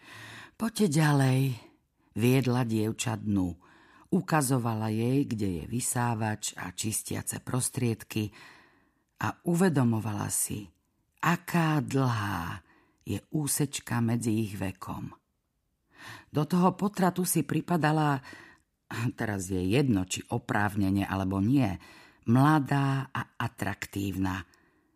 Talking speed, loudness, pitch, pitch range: 90 wpm, -29 LUFS, 120 Hz, 100-140 Hz